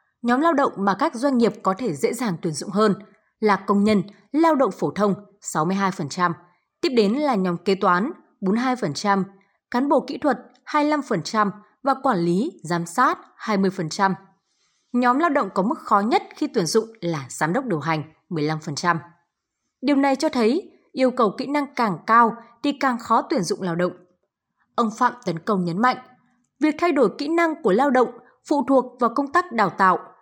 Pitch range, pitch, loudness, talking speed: 185-270 Hz, 220 Hz, -22 LUFS, 185 wpm